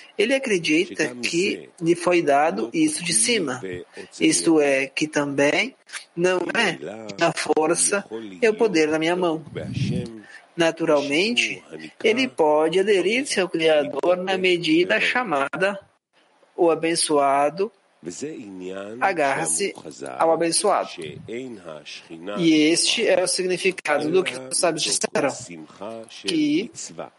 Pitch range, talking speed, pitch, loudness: 150-200 Hz, 110 wpm, 170 Hz, -21 LUFS